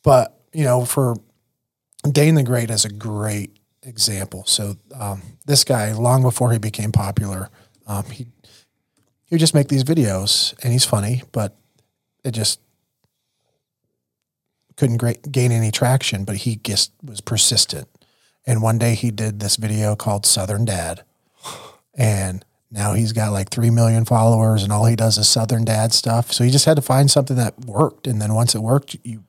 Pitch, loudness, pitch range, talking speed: 115 Hz, -18 LUFS, 105-125 Hz, 175 wpm